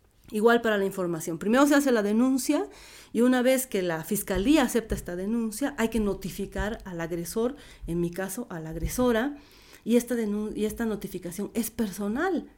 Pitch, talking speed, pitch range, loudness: 215 Hz, 175 wpm, 190-245 Hz, -27 LUFS